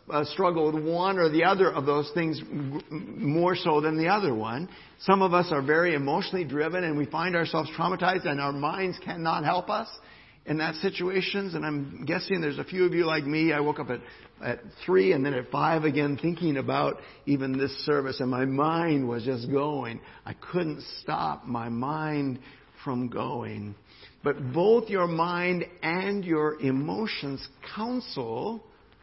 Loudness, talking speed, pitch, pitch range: -27 LUFS, 170 wpm, 155 Hz, 140-175 Hz